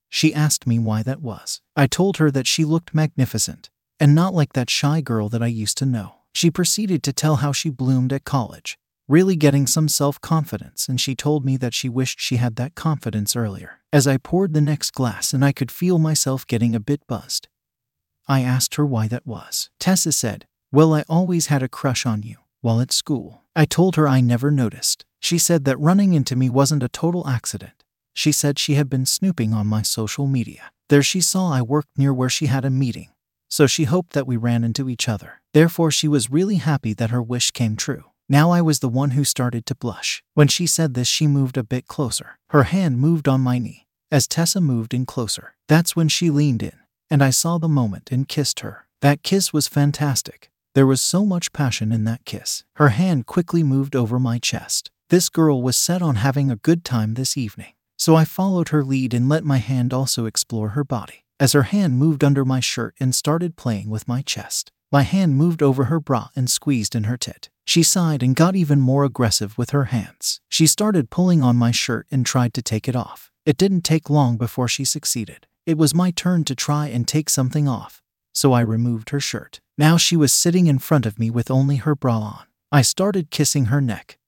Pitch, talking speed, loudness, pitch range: 140 Hz, 220 wpm, -19 LUFS, 120-155 Hz